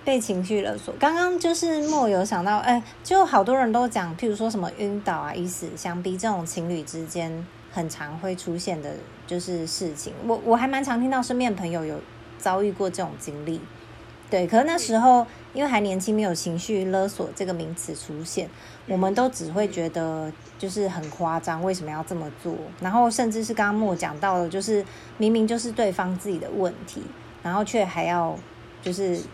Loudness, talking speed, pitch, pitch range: -25 LUFS, 285 characters per minute, 190 Hz, 170-225 Hz